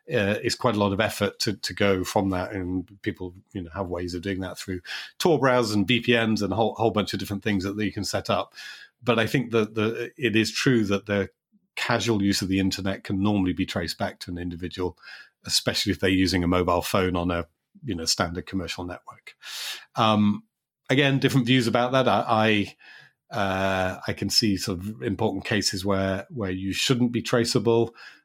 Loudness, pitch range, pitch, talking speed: -25 LUFS, 95-115 Hz, 100 Hz, 210 wpm